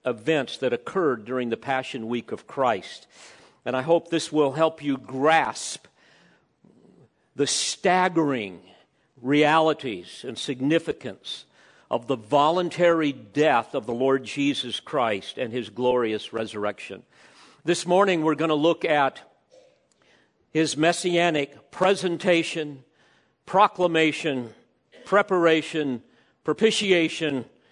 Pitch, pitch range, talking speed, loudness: 150 Hz, 130-170 Hz, 105 wpm, -24 LUFS